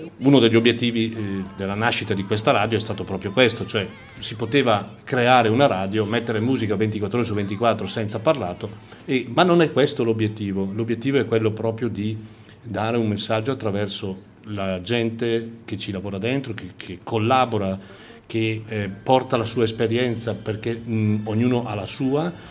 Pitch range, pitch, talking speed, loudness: 105-120 Hz, 110 Hz, 155 wpm, -22 LUFS